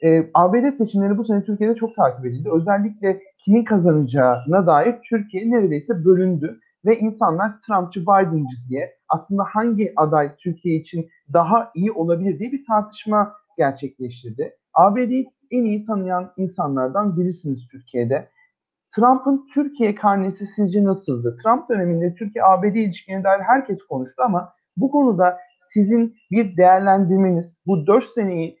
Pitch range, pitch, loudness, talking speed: 170-220 Hz, 195 Hz, -19 LUFS, 125 wpm